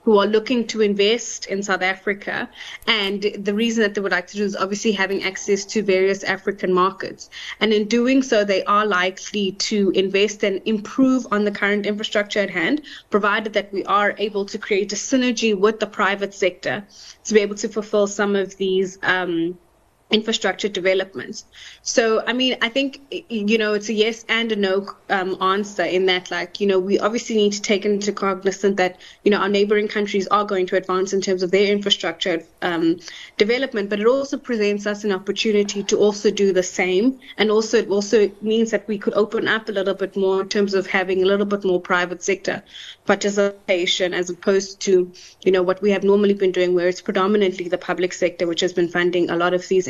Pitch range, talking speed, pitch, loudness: 190-215 Hz, 205 wpm, 200 Hz, -20 LUFS